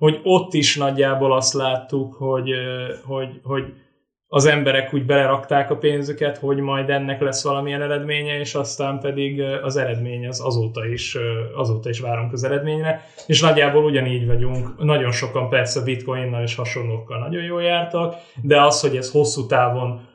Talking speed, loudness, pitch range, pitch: 160 wpm, -20 LUFS, 130-145 Hz, 135 Hz